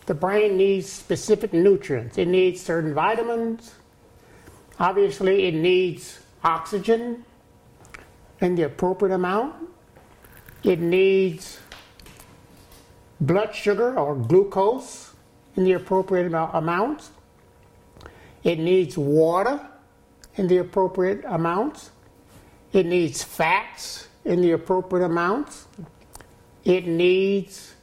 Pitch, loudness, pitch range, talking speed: 185 Hz, -22 LUFS, 175-200 Hz, 95 wpm